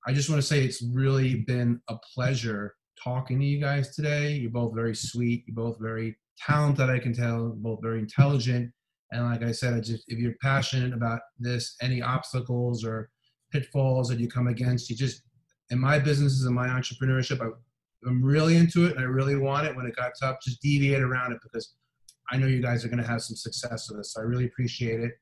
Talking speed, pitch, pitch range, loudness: 220 wpm, 125 Hz, 115-135 Hz, -27 LUFS